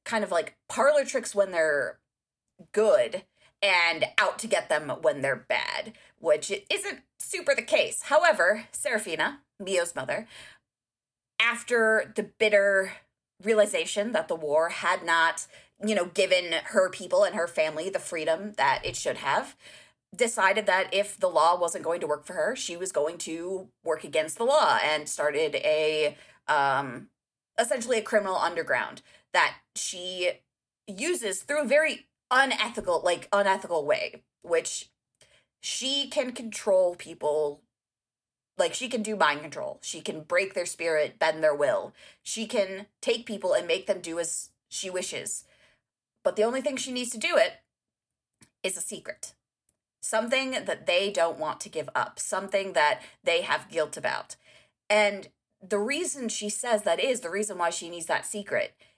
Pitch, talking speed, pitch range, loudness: 205 Hz, 160 wpm, 175-250 Hz, -27 LUFS